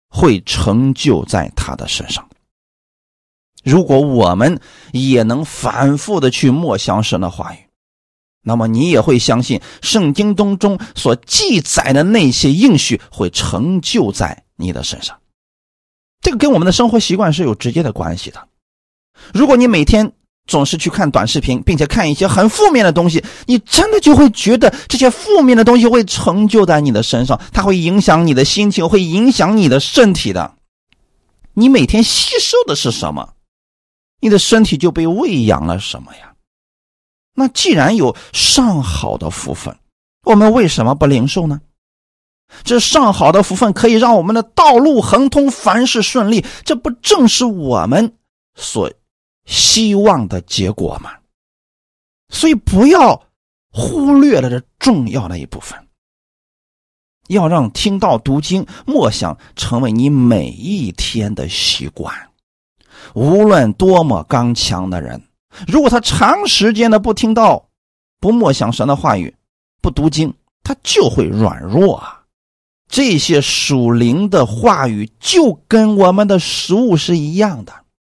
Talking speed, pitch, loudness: 220 characters per minute, 175 Hz, -12 LUFS